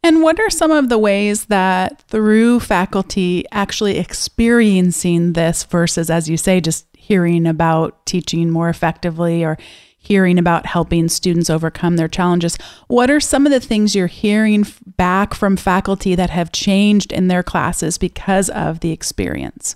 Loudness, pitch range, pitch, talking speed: -15 LUFS, 170-205 Hz, 185 Hz, 160 wpm